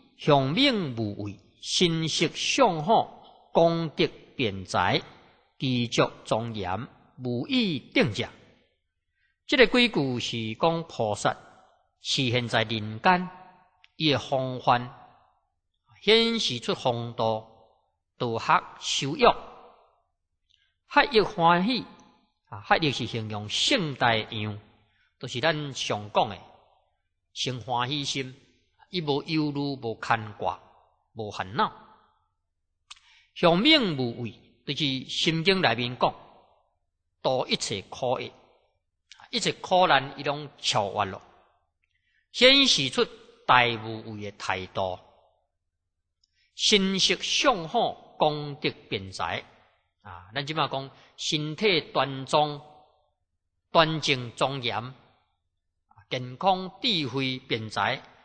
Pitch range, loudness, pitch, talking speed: 110-160 Hz, -25 LUFS, 130 Hz, 145 characters per minute